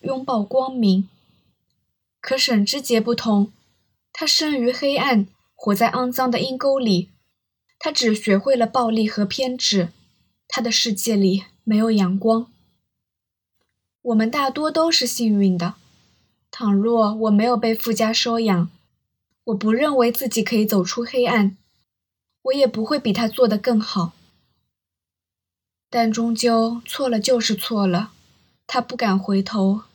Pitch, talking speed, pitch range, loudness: 225 Hz, 195 characters per minute, 195-250 Hz, -20 LUFS